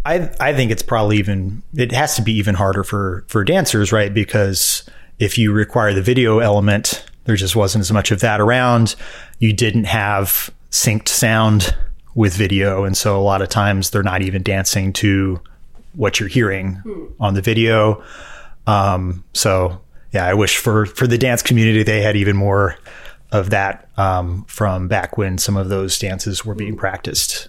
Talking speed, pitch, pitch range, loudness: 180 wpm, 105 Hz, 95-110 Hz, -16 LUFS